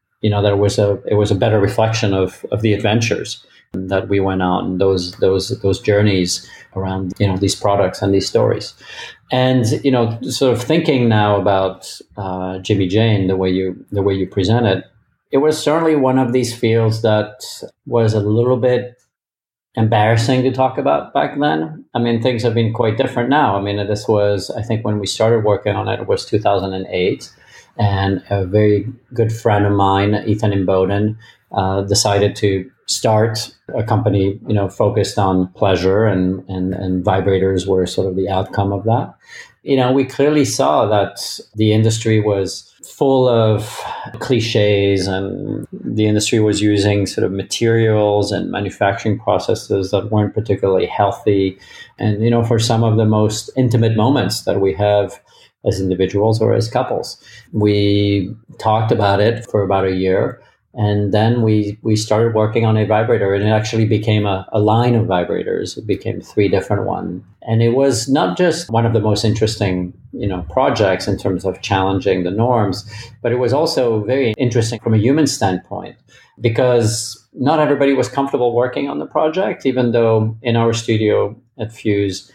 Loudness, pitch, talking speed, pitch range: -16 LUFS, 105 Hz, 175 wpm, 100-115 Hz